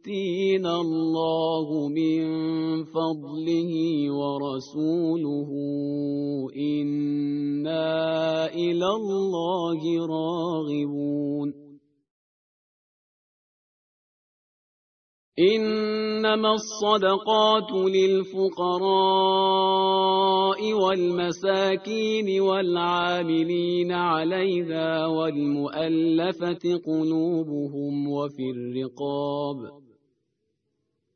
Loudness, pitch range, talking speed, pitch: -25 LUFS, 145-190 Hz, 35 wpm, 165 Hz